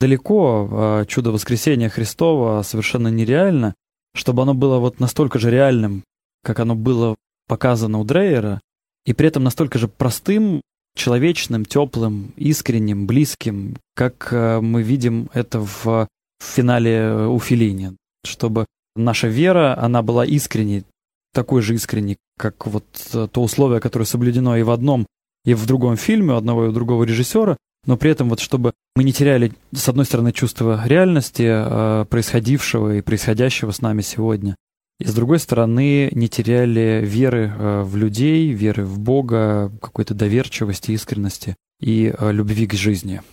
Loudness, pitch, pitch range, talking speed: -18 LUFS, 115 Hz, 110-130 Hz, 145 wpm